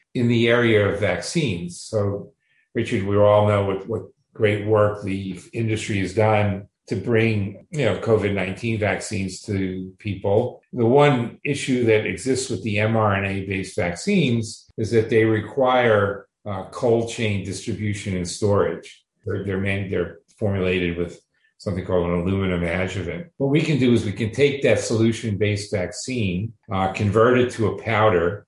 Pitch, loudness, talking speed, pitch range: 105 Hz, -22 LUFS, 155 wpm, 95-115 Hz